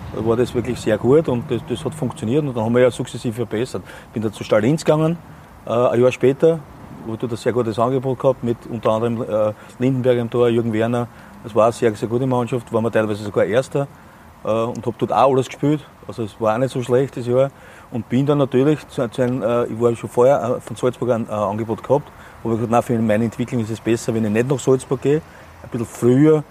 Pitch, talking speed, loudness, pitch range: 120 Hz, 220 wpm, -19 LUFS, 115-130 Hz